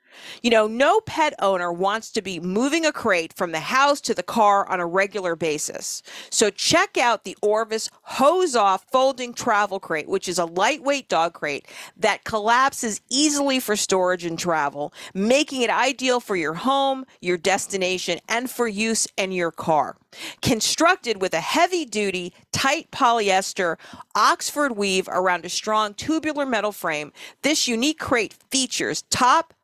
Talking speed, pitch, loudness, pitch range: 160 wpm, 215 Hz, -22 LUFS, 185-265 Hz